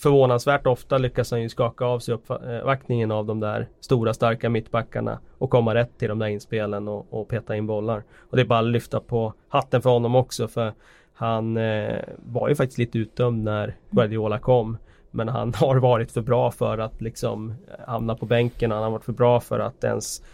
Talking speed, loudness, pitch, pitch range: 205 wpm, -24 LUFS, 115 Hz, 110-125 Hz